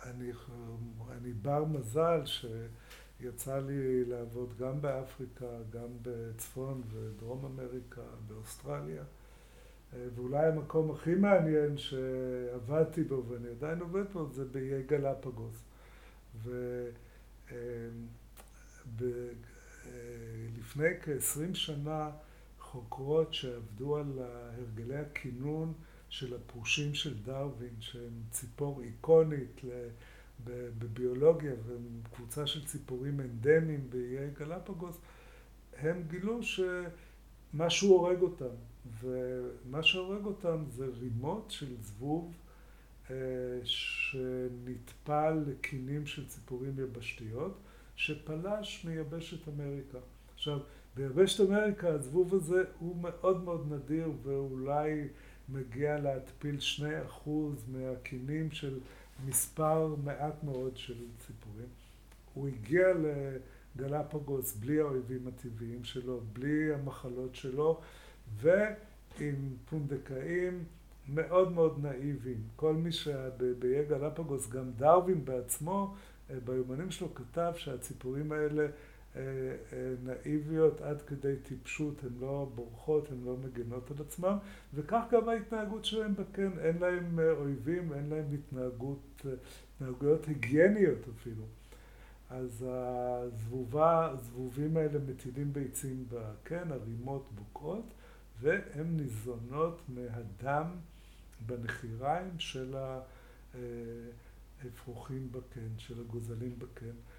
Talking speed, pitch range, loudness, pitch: 95 wpm, 125-155 Hz, -35 LUFS, 135 Hz